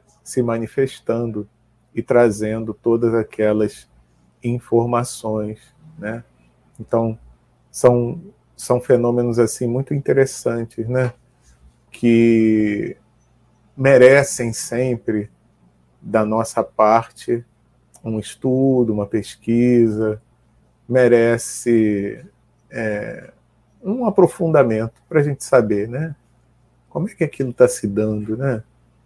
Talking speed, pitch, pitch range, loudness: 90 wpm, 115 Hz, 110-125 Hz, -18 LUFS